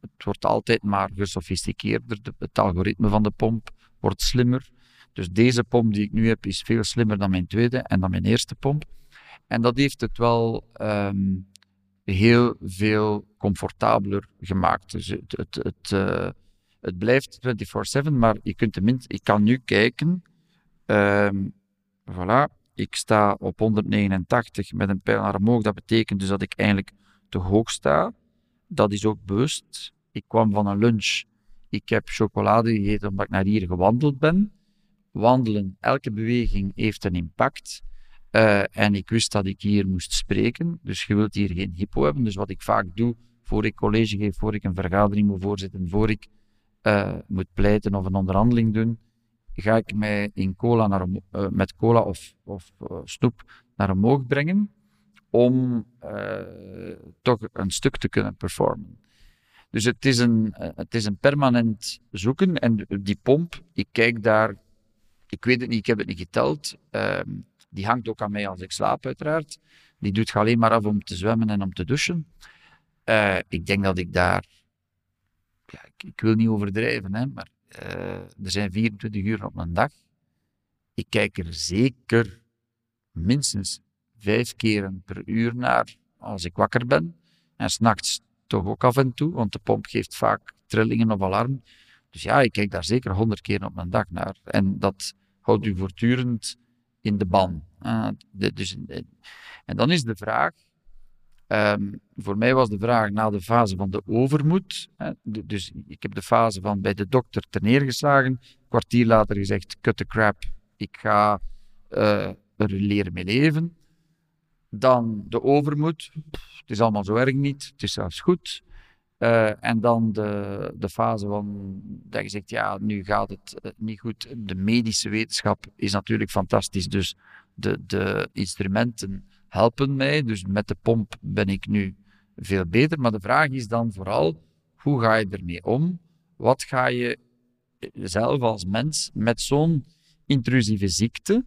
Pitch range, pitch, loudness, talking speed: 100-120 Hz, 110 Hz, -23 LUFS, 170 wpm